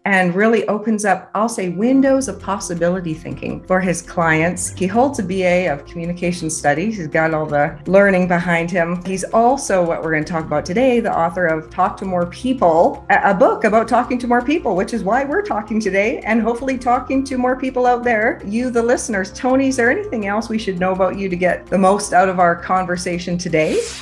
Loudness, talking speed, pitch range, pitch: -17 LUFS, 215 wpm, 175-235 Hz, 190 Hz